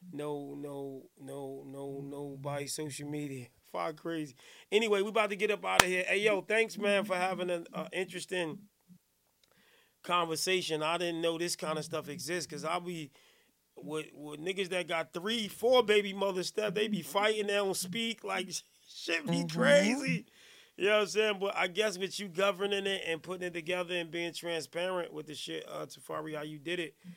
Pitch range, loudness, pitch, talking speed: 155-200 Hz, -33 LUFS, 180 Hz, 190 wpm